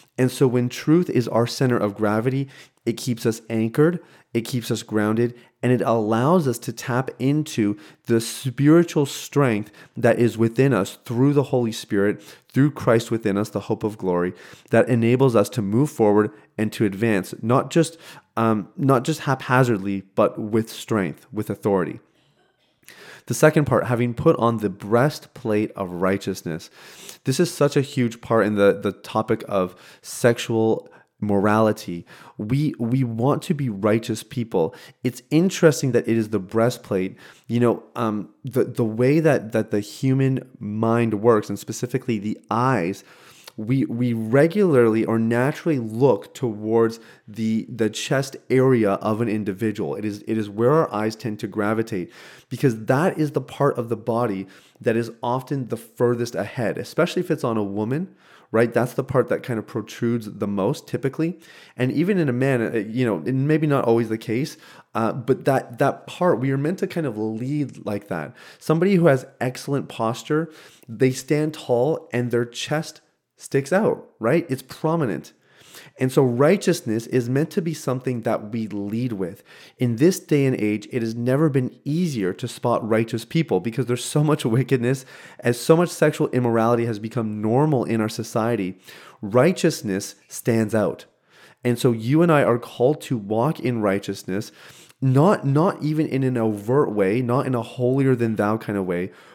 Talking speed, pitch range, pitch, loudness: 175 wpm, 110-140 Hz, 120 Hz, -22 LUFS